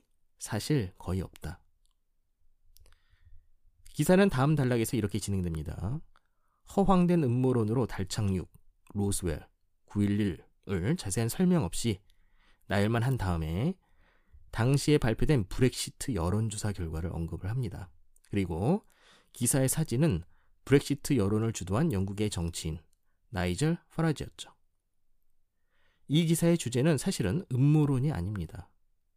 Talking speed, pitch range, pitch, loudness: 260 characters per minute, 85-135 Hz, 105 Hz, -30 LUFS